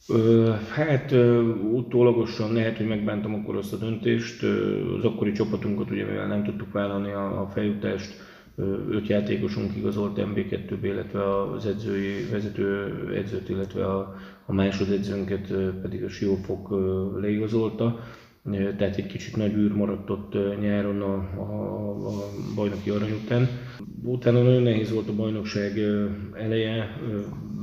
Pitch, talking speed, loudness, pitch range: 105 Hz, 125 wpm, -26 LUFS, 100-110 Hz